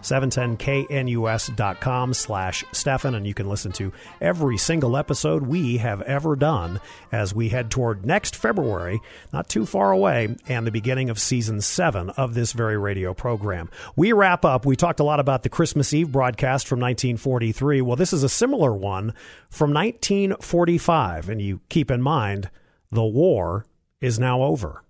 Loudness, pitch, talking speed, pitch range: -22 LUFS, 125 Hz, 165 wpm, 110-145 Hz